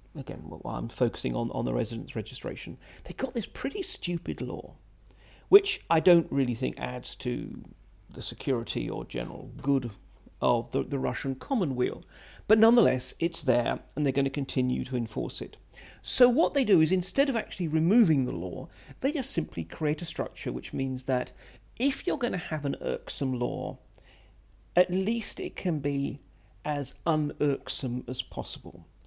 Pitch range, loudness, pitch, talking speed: 130-190 Hz, -29 LUFS, 145 Hz, 165 wpm